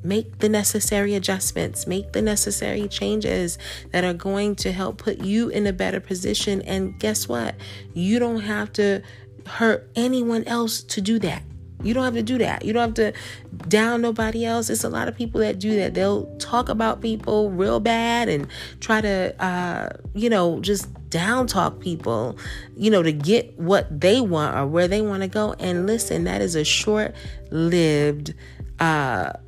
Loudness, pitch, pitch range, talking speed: -22 LUFS, 200 Hz, 170-220 Hz, 185 wpm